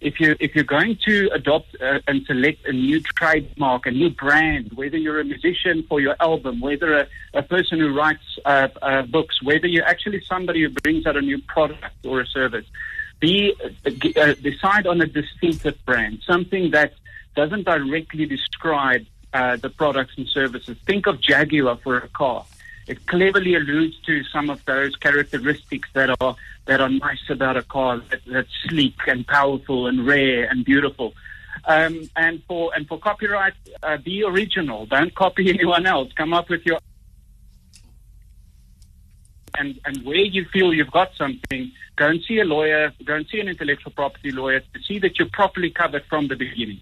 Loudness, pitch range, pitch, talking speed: -20 LUFS, 135-175 Hz, 150 Hz, 180 wpm